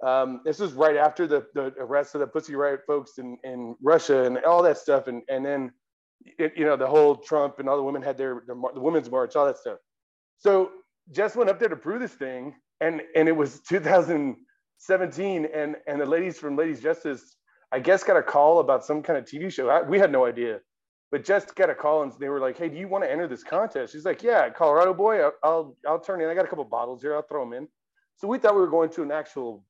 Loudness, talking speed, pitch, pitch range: -24 LUFS, 255 wpm, 150 Hz, 135-175 Hz